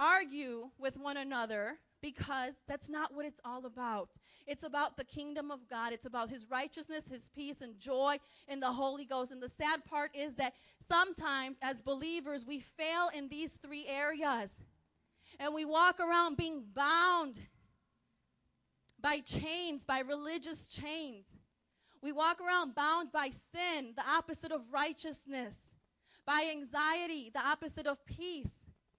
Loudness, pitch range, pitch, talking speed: -37 LUFS, 270-315 Hz, 290 Hz, 145 wpm